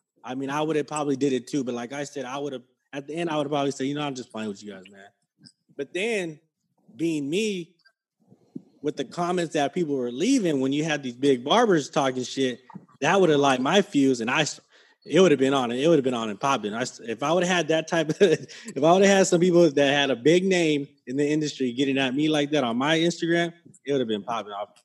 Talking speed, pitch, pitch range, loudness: 270 wpm, 145 Hz, 135-170 Hz, -24 LUFS